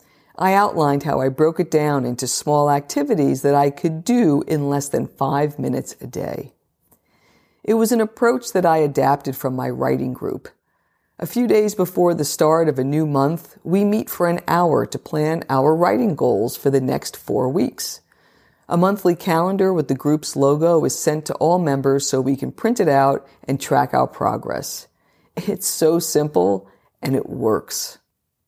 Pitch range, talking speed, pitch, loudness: 140-175 Hz, 180 wpm, 155 Hz, -19 LUFS